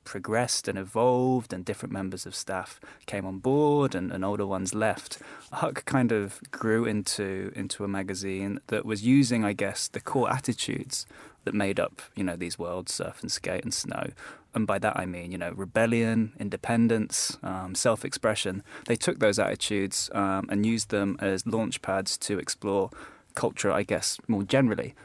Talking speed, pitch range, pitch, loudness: 175 wpm, 95-115 Hz, 100 Hz, -28 LUFS